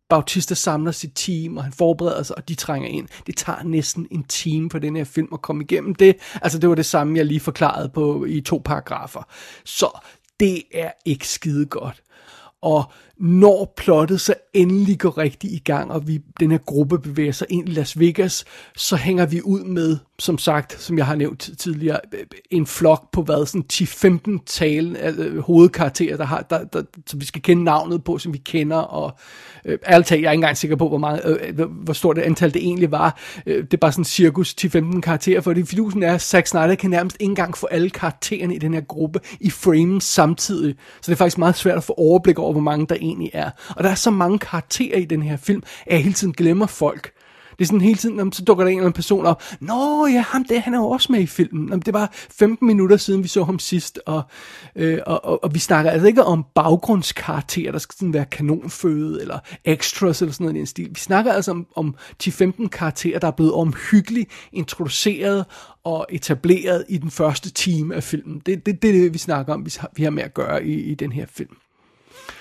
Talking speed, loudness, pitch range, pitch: 230 wpm, -19 LUFS, 155-185 Hz, 170 Hz